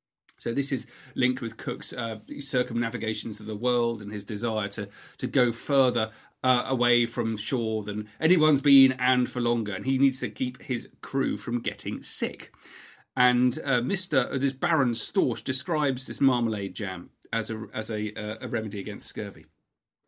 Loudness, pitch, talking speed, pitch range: -27 LUFS, 120 Hz, 175 wpm, 110-130 Hz